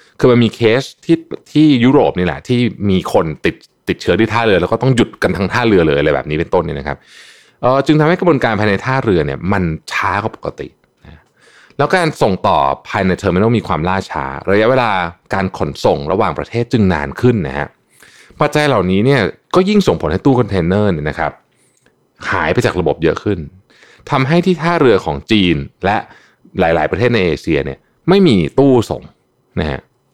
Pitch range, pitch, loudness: 95-145 Hz, 115 Hz, -14 LUFS